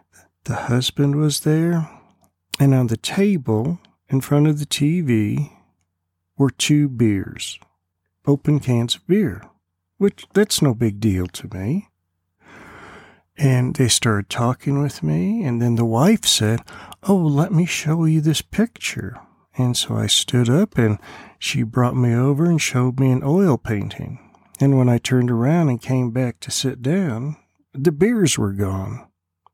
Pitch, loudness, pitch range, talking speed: 130 Hz, -19 LUFS, 110-150 Hz, 155 wpm